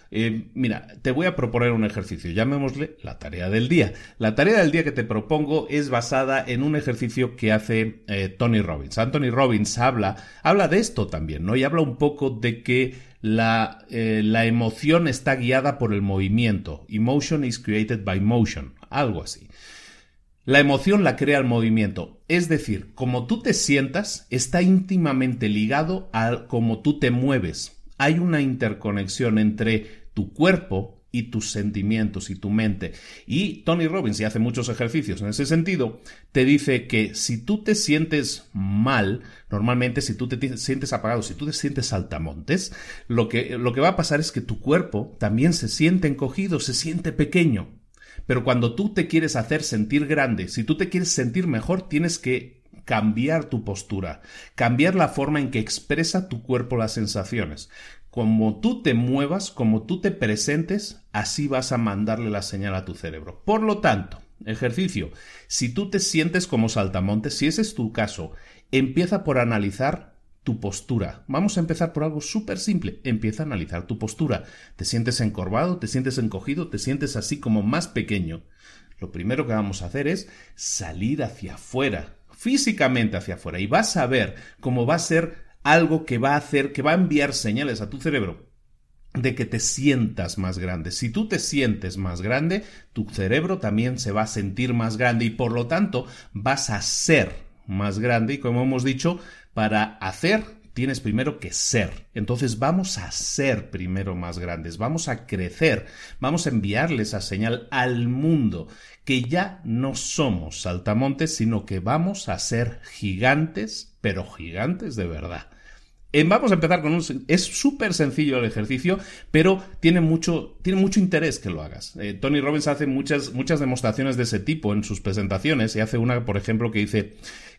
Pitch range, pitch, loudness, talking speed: 105-150 Hz, 120 Hz, -23 LUFS, 175 wpm